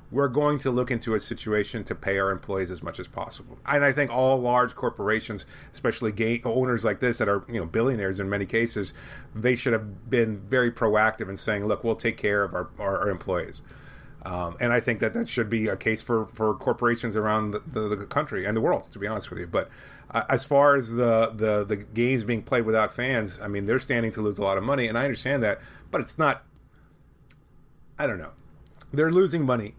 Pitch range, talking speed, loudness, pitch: 105-125 Hz, 230 wpm, -26 LUFS, 115 Hz